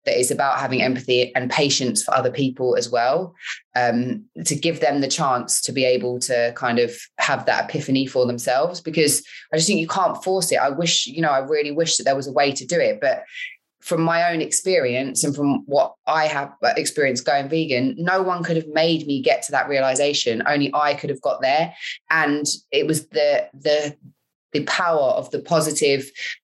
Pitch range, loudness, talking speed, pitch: 130-165 Hz, -20 LUFS, 205 wpm, 145 Hz